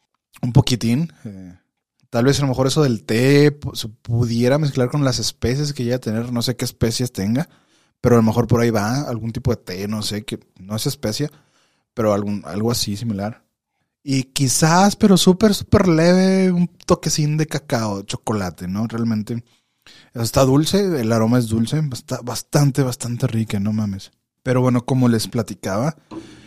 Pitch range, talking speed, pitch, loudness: 110-145 Hz, 180 wpm, 125 Hz, -19 LUFS